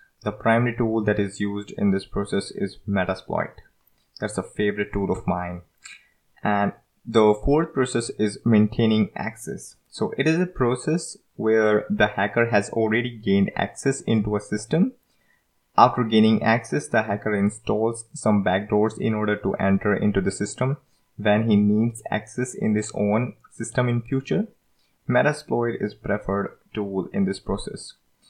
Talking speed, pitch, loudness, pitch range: 150 wpm, 105 Hz, -23 LUFS, 100-120 Hz